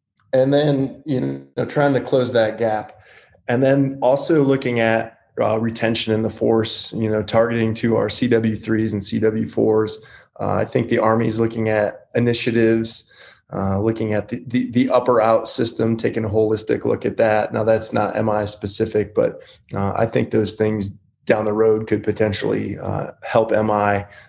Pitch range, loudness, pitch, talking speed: 105-115 Hz, -19 LUFS, 110 Hz, 175 wpm